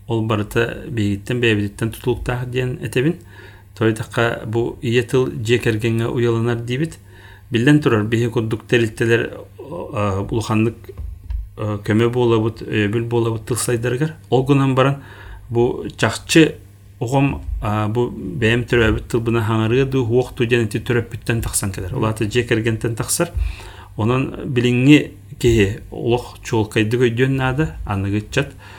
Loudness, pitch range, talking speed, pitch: -19 LUFS, 105-125 Hz, 110 wpm, 115 Hz